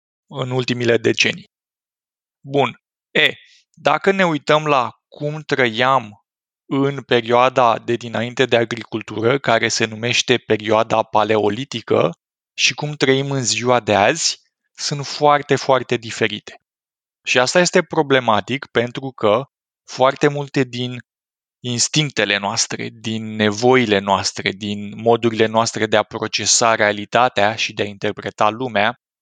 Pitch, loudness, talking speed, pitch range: 120 Hz, -18 LUFS, 120 wpm, 110-135 Hz